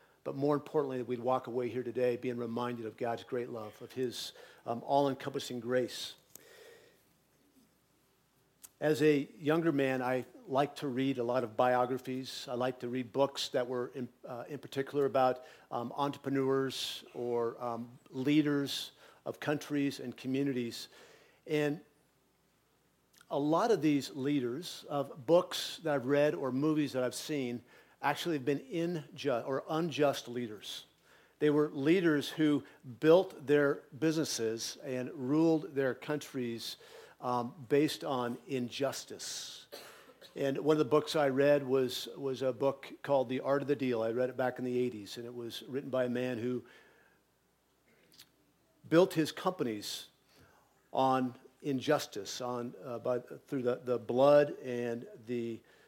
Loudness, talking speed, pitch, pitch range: -34 LUFS, 145 wpm, 135 Hz, 125-145 Hz